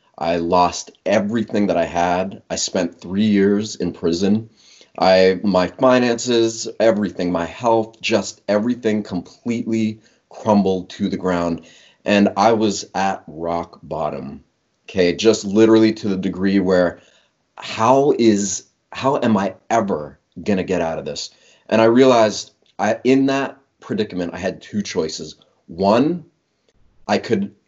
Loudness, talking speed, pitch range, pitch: -19 LUFS, 140 wpm, 90-115 Hz, 105 Hz